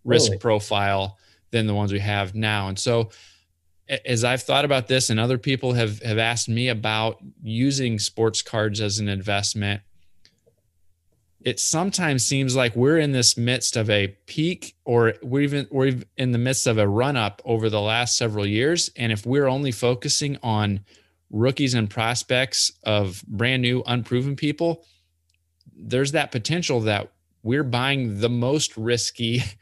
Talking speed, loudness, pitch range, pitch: 160 wpm, -22 LUFS, 105-130 Hz, 115 Hz